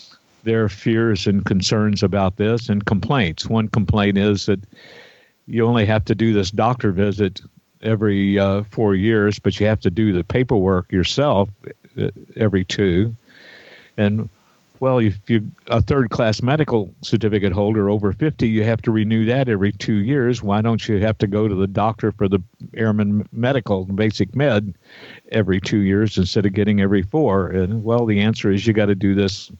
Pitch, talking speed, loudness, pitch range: 105 Hz, 175 wpm, -19 LUFS, 100-115 Hz